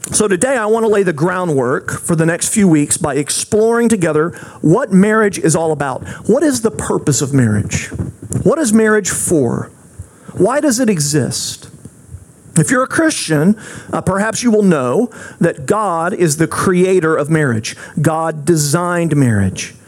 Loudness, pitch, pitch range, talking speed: -14 LUFS, 170 Hz, 150-210 Hz, 165 wpm